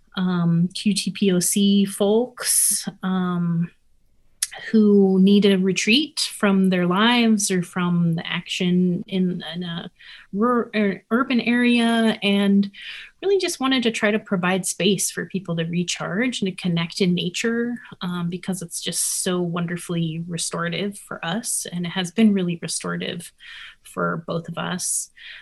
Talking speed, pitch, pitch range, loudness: 135 wpm, 190 Hz, 175-210 Hz, -21 LUFS